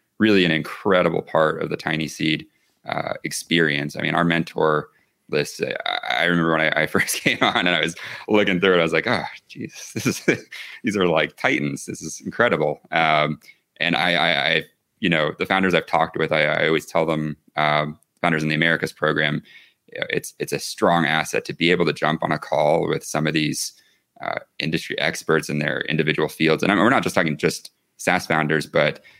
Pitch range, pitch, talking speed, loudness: 75-85 Hz, 80 Hz, 210 wpm, -21 LUFS